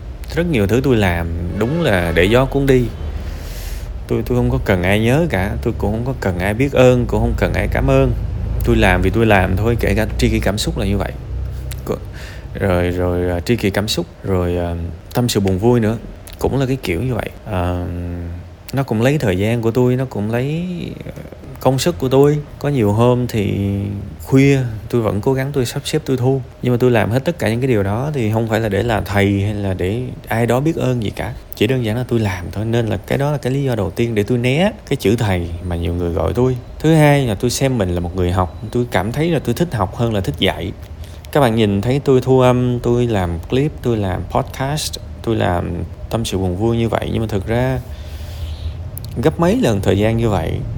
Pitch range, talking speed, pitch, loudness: 95-125 Hz, 240 wpm, 110 Hz, -17 LUFS